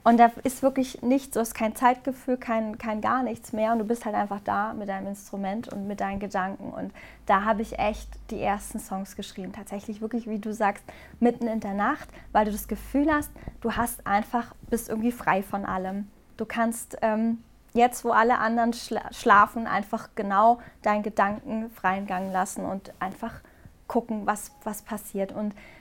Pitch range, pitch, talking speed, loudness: 205-235 Hz, 220 Hz, 190 wpm, -27 LUFS